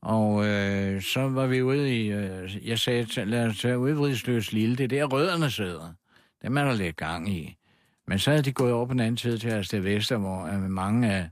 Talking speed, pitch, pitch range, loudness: 240 wpm, 110 Hz, 100-125 Hz, -26 LUFS